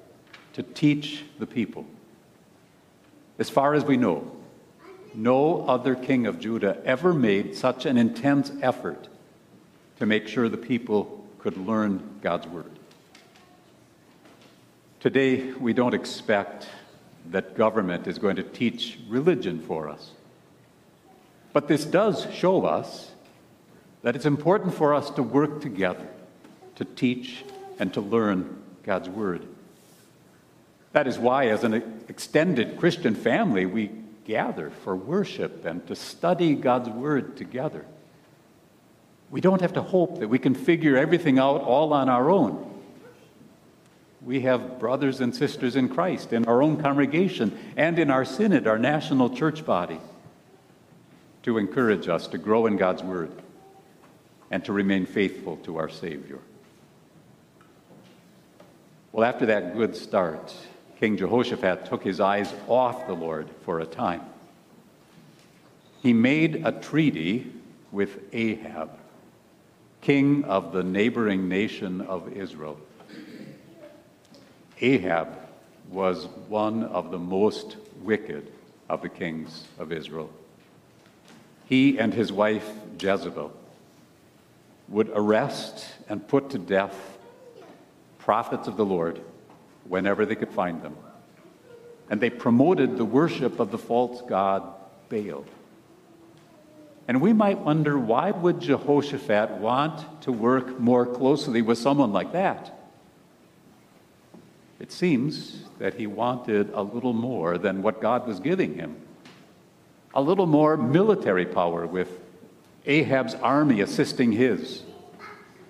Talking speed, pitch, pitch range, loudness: 125 wpm, 120 Hz, 100-140 Hz, -25 LUFS